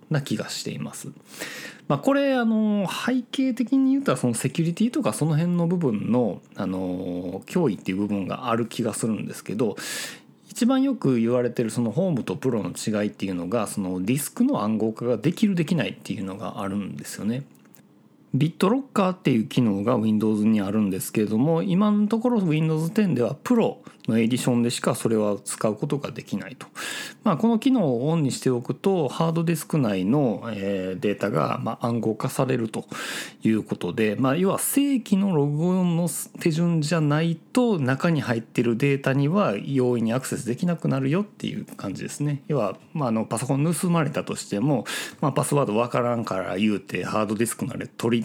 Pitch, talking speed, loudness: 140 Hz, 405 characters per minute, -24 LUFS